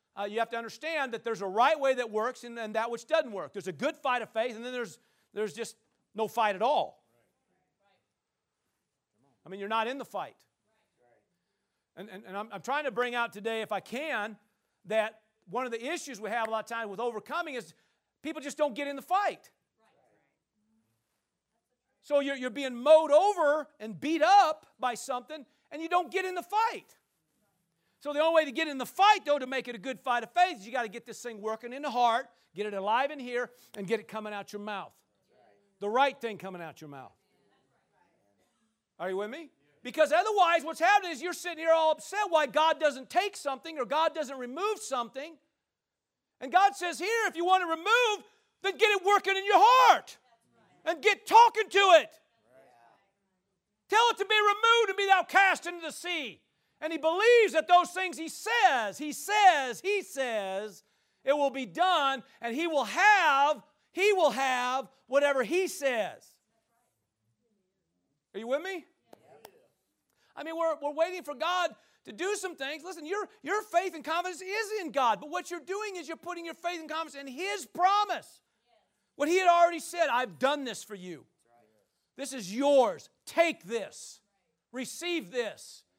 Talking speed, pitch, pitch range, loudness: 195 wpm, 285 Hz, 230-345 Hz, -28 LUFS